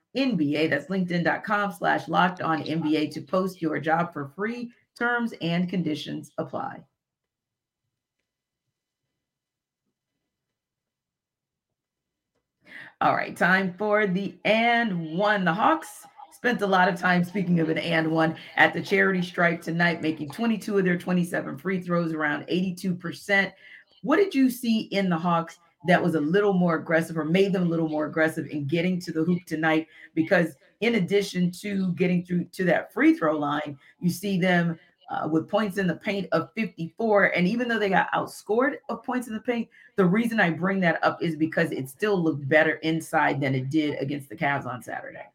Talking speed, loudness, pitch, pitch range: 170 wpm, -25 LUFS, 175 Hz, 160-200 Hz